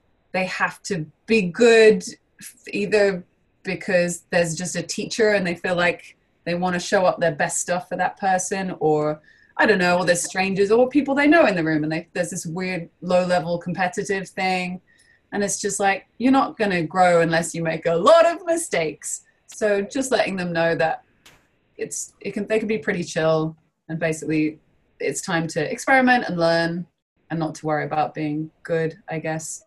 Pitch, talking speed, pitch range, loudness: 180 Hz, 190 wpm, 165-205 Hz, -21 LUFS